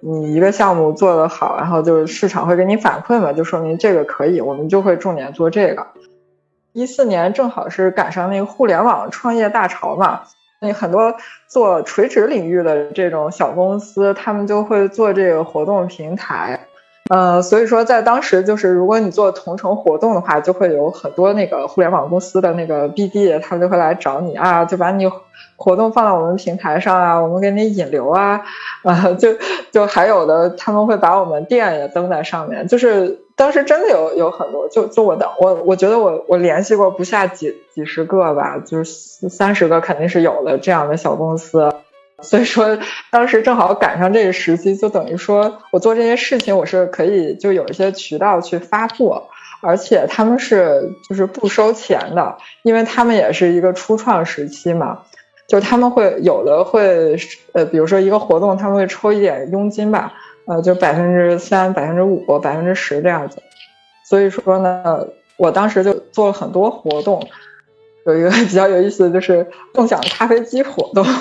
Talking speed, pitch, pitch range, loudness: 285 characters per minute, 190 Hz, 175-215 Hz, -15 LUFS